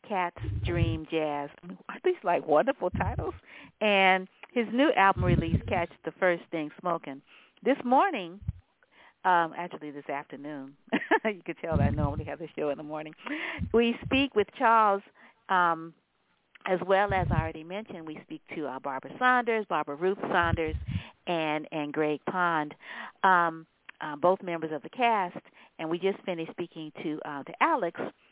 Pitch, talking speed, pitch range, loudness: 175 Hz, 160 wpm, 150-200 Hz, -29 LUFS